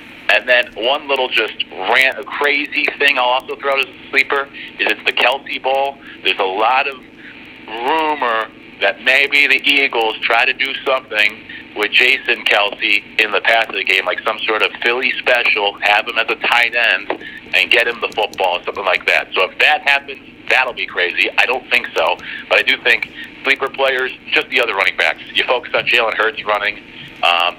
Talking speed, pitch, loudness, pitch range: 200 wpm, 135 Hz, -14 LUFS, 125-140 Hz